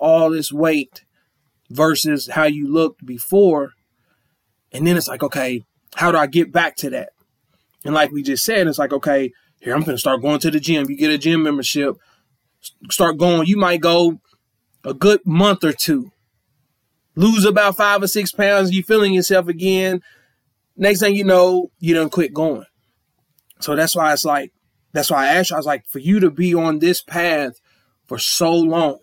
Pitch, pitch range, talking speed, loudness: 160 Hz, 145-180 Hz, 190 wpm, -17 LUFS